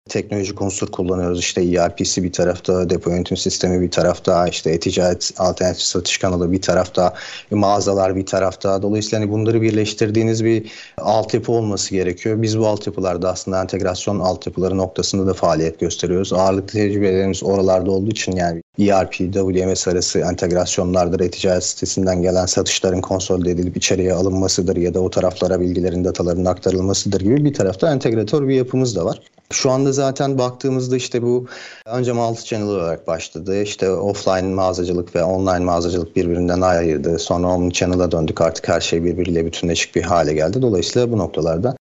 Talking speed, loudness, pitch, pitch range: 155 wpm, -18 LUFS, 95 Hz, 90-105 Hz